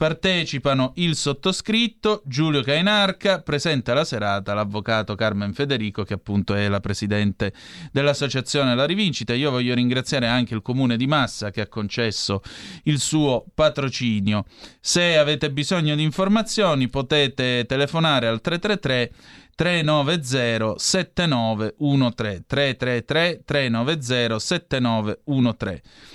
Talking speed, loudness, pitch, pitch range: 110 wpm, -21 LUFS, 135 Hz, 115-155 Hz